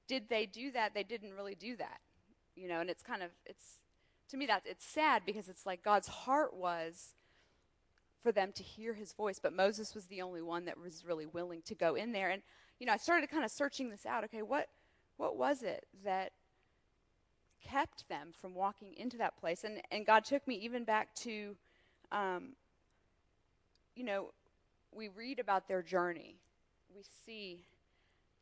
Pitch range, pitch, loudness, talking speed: 180-230 Hz, 205 Hz, -39 LUFS, 185 wpm